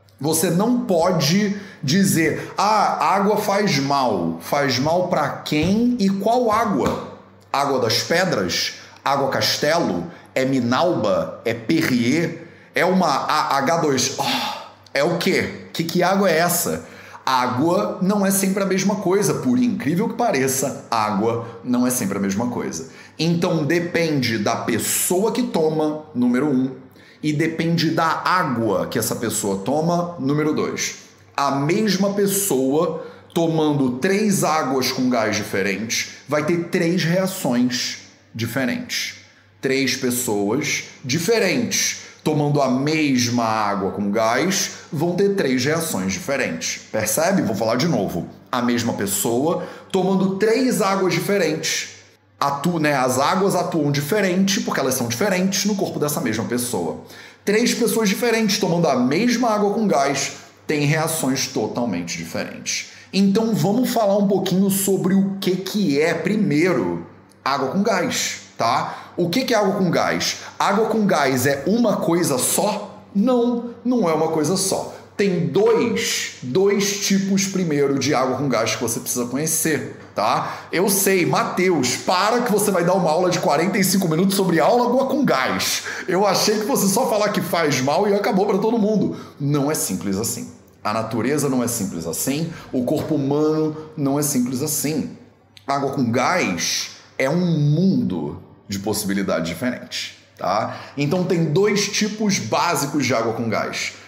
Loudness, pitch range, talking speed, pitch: -20 LUFS, 130-200 Hz, 150 wpm, 165 Hz